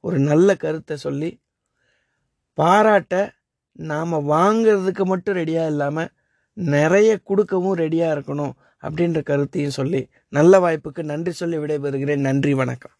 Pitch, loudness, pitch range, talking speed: 160 Hz, -20 LUFS, 145-190 Hz, 110 wpm